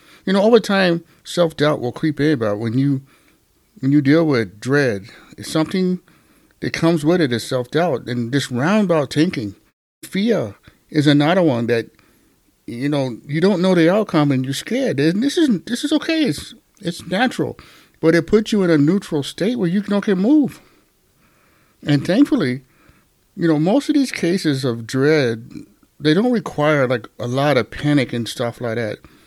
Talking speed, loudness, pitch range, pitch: 180 wpm, -18 LUFS, 135-190 Hz, 155 Hz